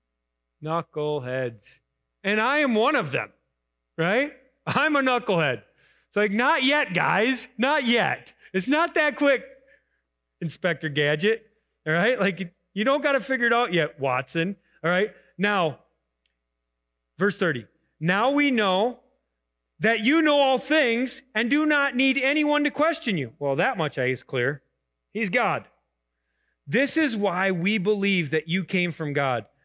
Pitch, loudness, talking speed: 190 Hz, -24 LUFS, 150 wpm